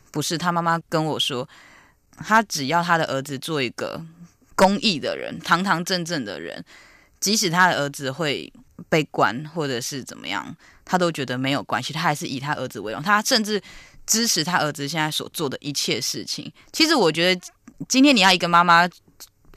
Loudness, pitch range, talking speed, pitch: -21 LUFS, 140-185 Hz, 275 characters per minute, 165 Hz